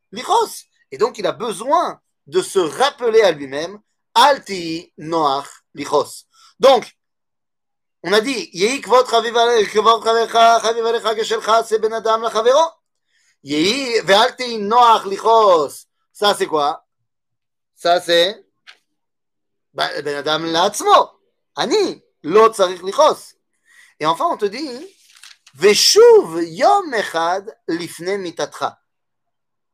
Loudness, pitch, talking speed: -16 LUFS, 225 Hz, 105 wpm